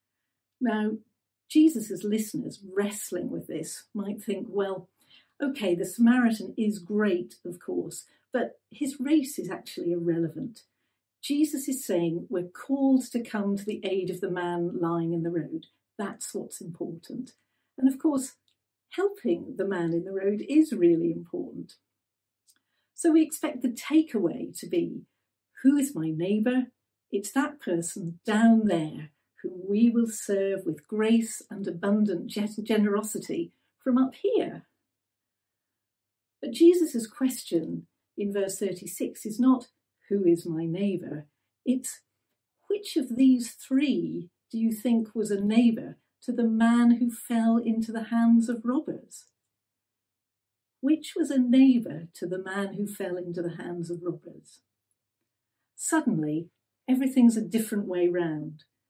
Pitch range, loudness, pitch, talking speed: 175-250 Hz, -27 LUFS, 210 Hz, 140 wpm